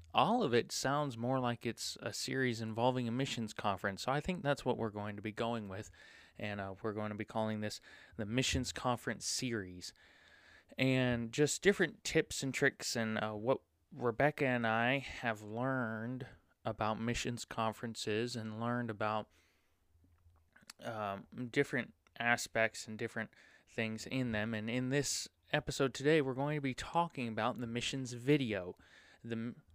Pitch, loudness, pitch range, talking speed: 115 Hz, -37 LUFS, 110-130 Hz, 160 wpm